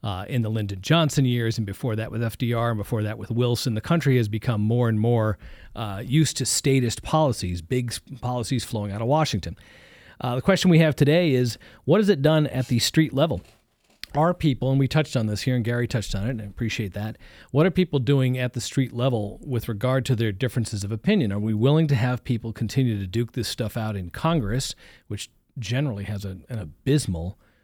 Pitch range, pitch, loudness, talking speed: 110-135 Hz, 120 Hz, -24 LUFS, 220 wpm